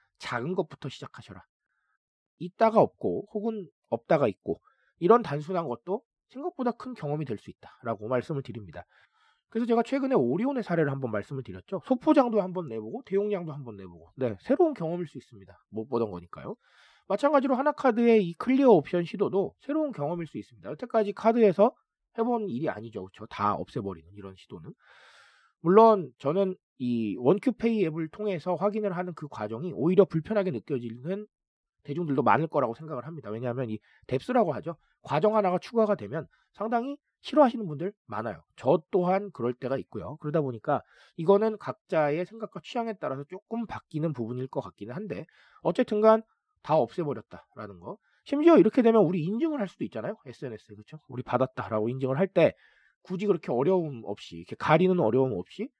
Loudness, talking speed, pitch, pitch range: -27 LUFS, 395 characters per minute, 175 Hz, 130-215 Hz